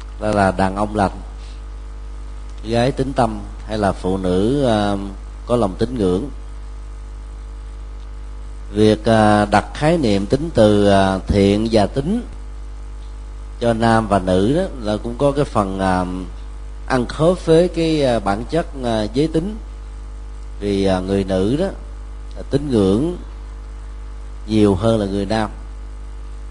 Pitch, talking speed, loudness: 100 Hz, 140 wpm, -18 LUFS